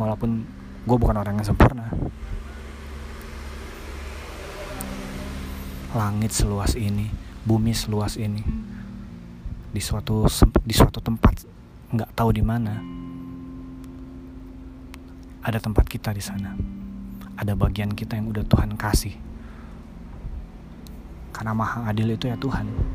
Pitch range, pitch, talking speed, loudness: 75-110 Hz, 100 Hz, 100 wpm, -25 LUFS